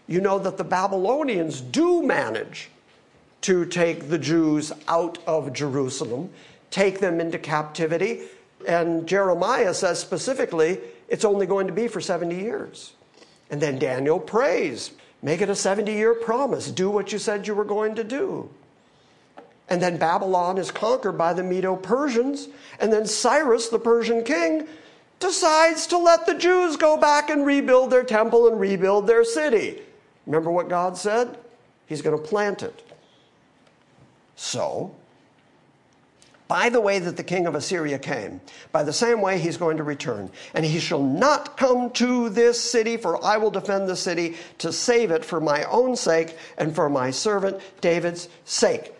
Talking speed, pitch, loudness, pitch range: 165 wpm, 195 Hz, -22 LUFS, 170-235 Hz